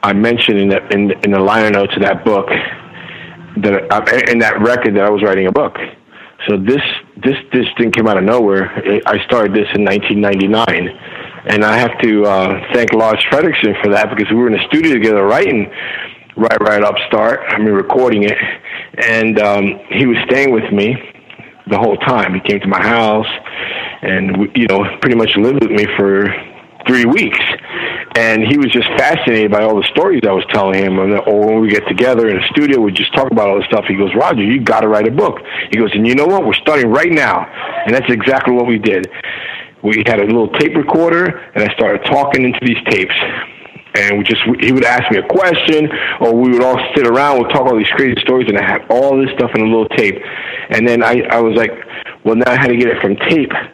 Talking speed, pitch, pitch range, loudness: 225 wpm, 110 Hz, 105-125 Hz, -12 LUFS